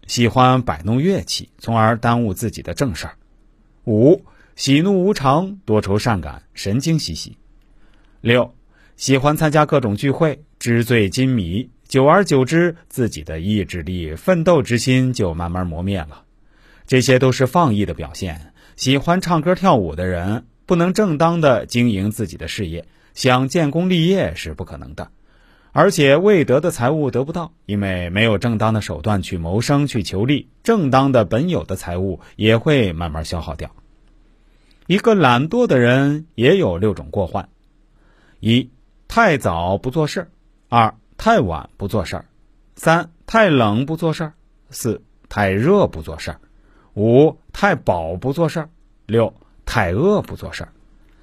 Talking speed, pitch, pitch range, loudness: 220 characters per minute, 120 Hz, 100-155 Hz, -18 LUFS